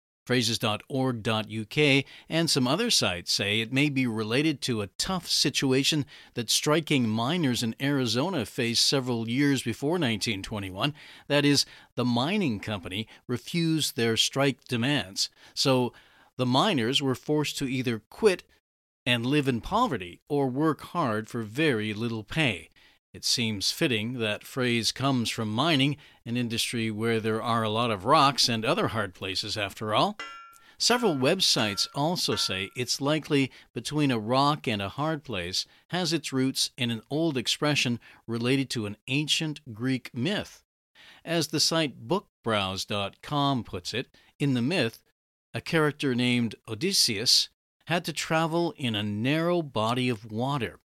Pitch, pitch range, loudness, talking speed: 125 Hz, 110-145 Hz, -27 LUFS, 145 wpm